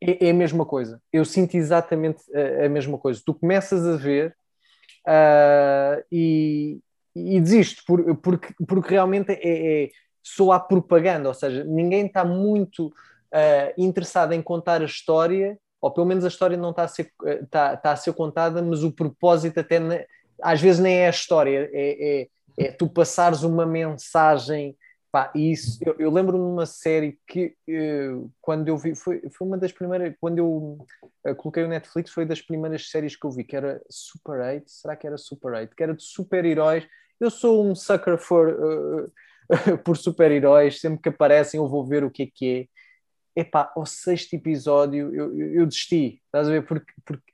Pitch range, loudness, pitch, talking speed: 150-175 Hz, -22 LUFS, 160 Hz, 185 wpm